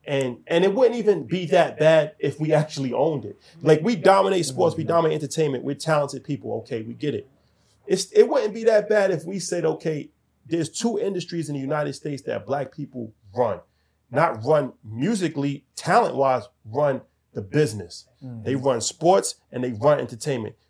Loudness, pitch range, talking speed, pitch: -23 LUFS, 130-170 Hz, 180 wpm, 150 Hz